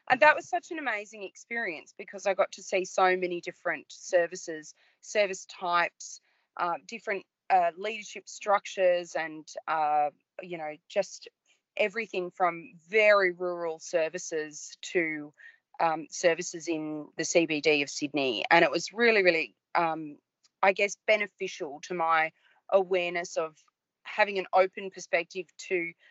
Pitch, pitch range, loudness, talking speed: 180 Hz, 165-200 Hz, -28 LUFS, 135 wpm